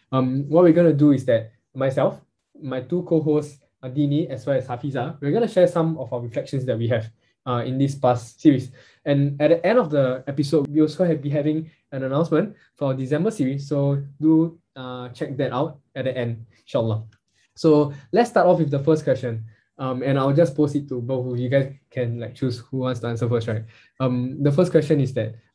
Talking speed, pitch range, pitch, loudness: 225 wpm, 125-155 Hz, 140 Hz, -22 LUFS